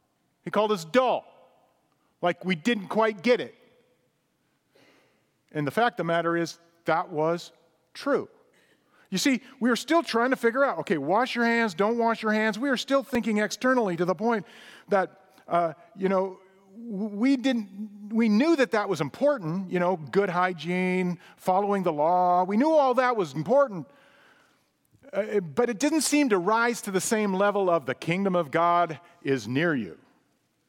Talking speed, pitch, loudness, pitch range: 175 wpm, 205 Hz, -26 LUFS, 175-240 Hz